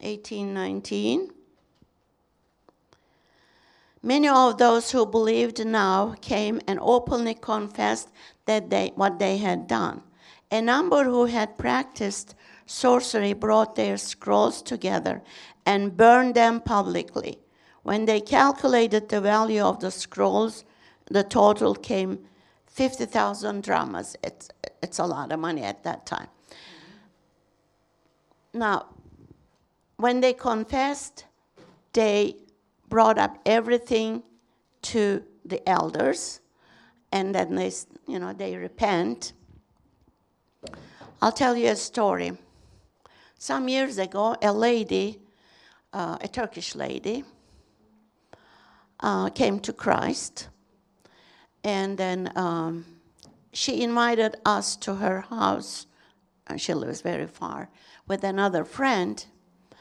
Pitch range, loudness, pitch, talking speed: 190-235 Hz, -25 LUFS, 210 Hz, 110 wpm